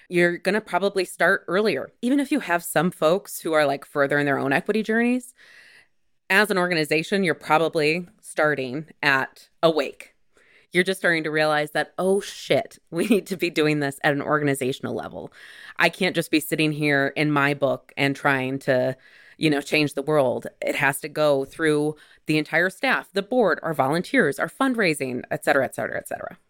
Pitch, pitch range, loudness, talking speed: 155 Hz, 145-185 Hz, -23 LUFS, 190 wpm